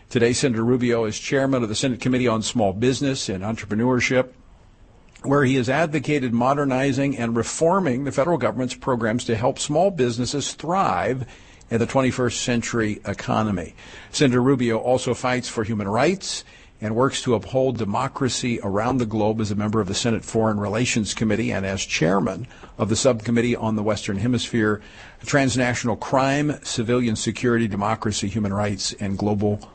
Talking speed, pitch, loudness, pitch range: 155 wpm, 120 Hz, -22 LUFS, 110-130 Hz